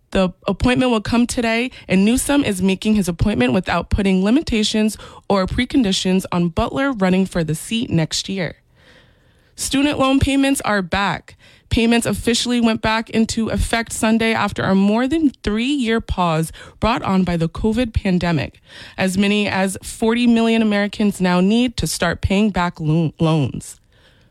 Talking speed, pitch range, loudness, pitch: 155 wpm, 180-230 Hz, -18 LUFS, 205 Hz